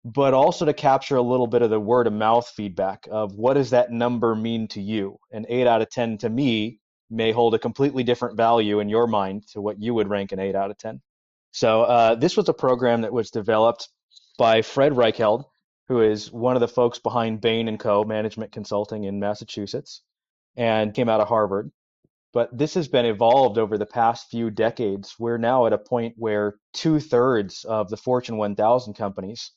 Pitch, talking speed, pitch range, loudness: 115 Hz, 200 wpm, 105-120 Hz, -22 LUFS